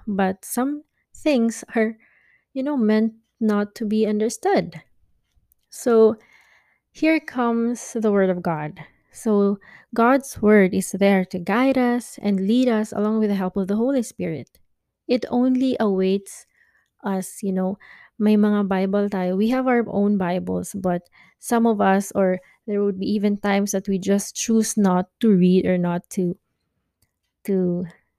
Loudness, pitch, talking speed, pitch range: -21 LUFS, 205 Hz, 155 wpm, 190-230 Hz